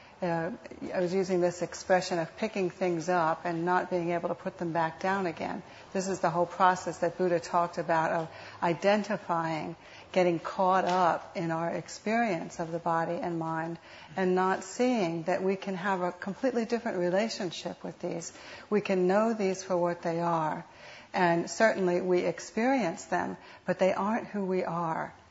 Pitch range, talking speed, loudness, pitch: 170-190 Hz, 175 wpm, -30 LUFS, 180 Hz